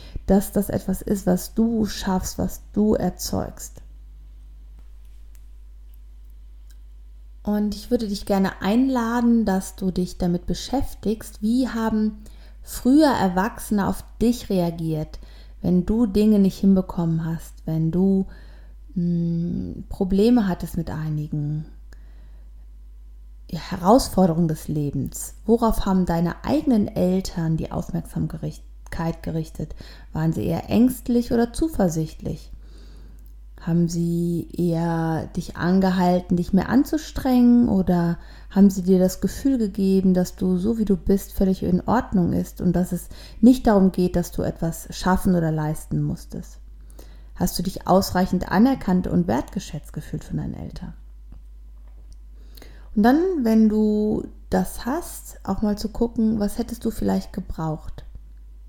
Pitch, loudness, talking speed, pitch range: 180 Hz, -22 LUFS, 125 wpm, 155-210 Hz